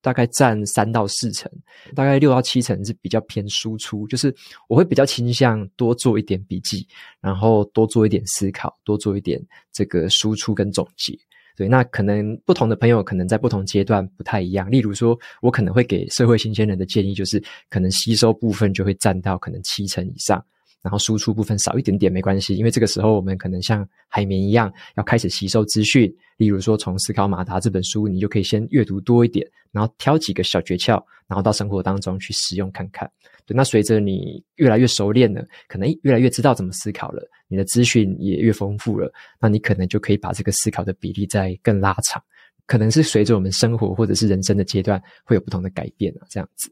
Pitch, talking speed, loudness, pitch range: 105 Hz, 335 characters per minute, -19 LUFS, 100-115 Hz